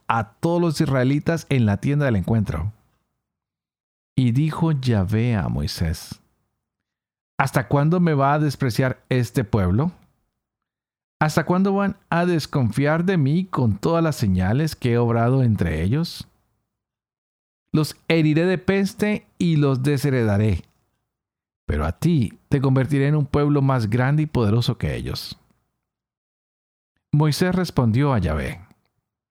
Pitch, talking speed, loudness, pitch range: 135 Hz, 130 wpm, -21 LUFS, 110-155 Hz